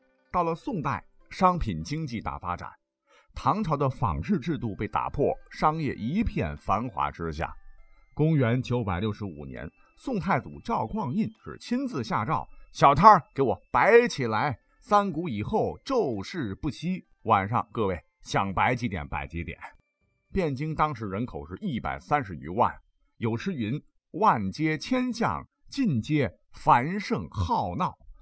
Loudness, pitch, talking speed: -27 LUFS, 125 Hz, 205 characters per minute